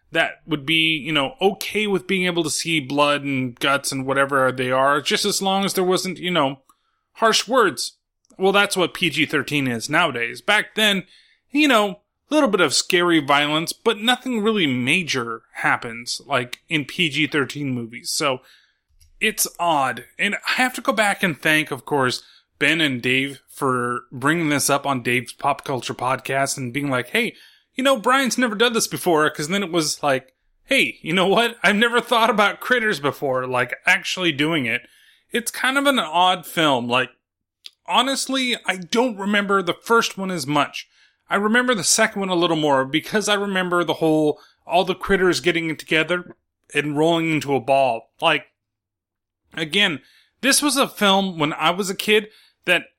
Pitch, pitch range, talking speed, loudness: 165 Hz, 140-205 Hz, 180 wpm, -20 LUFS